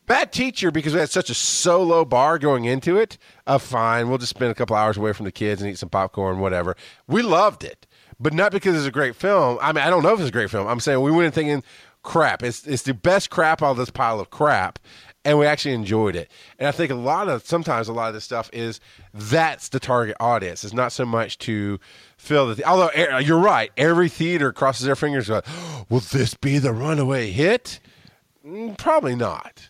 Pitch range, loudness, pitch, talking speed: 115-160 Hz, -21 LUFS, 135 Hz, 230 wpm